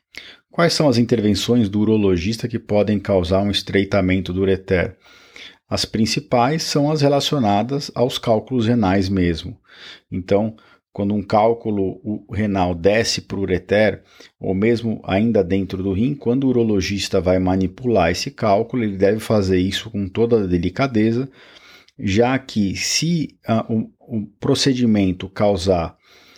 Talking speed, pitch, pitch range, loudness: 140 wpm, 105 Hz, 95-120 Hz, -19 LUFS